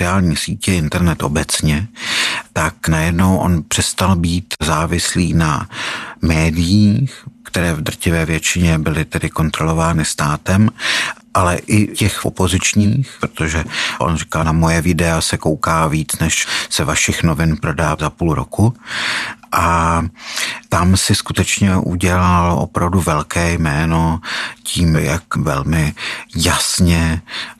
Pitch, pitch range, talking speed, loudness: 85 Hz, 80-95 Hz, 115 wpm, -16 LUFS